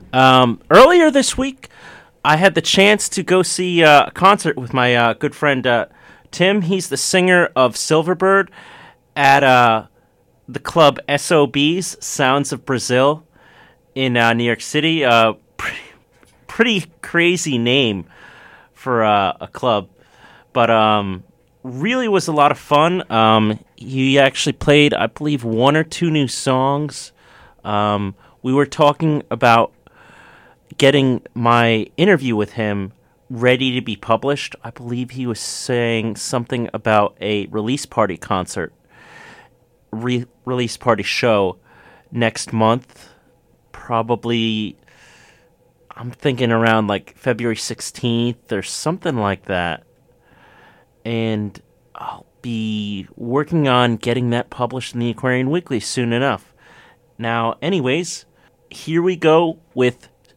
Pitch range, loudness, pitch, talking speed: 115-150 Hz, -17 LUFS, 125 Hz, 130 wpm